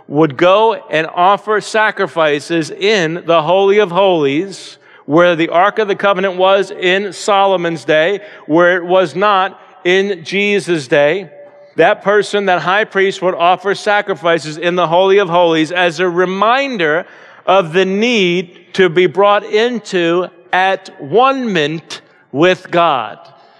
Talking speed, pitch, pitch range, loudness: 135 wpm, 185 Hz, 175-200 Hz, -13 LUFS